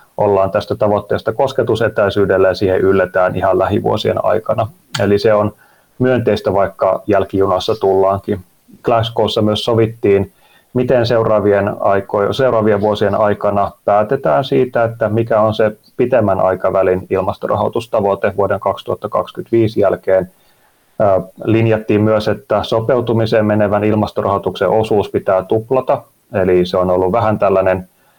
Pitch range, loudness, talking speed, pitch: 100-115 Hz, -15 LUFS, 110 wpm, 105 Hz